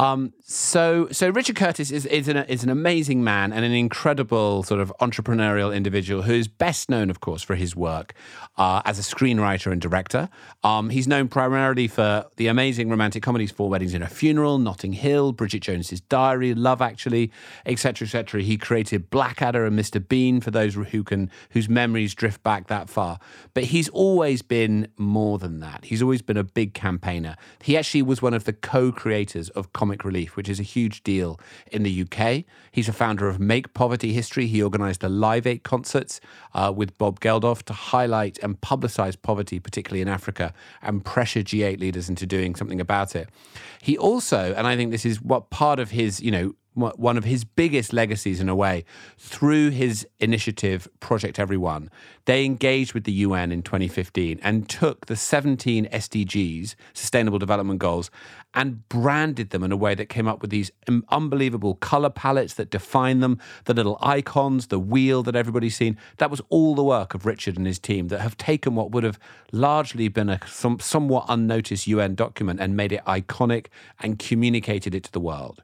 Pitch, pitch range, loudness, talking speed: 110 Hz, 100-125 Hz, -23 LUFS, 190 wpm